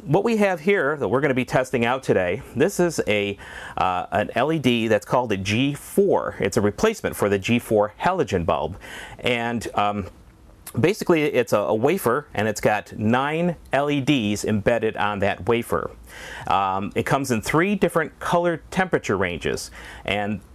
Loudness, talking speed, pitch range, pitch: -22 LUFS, 165 wpm, 105-150 Hz, 120 Hz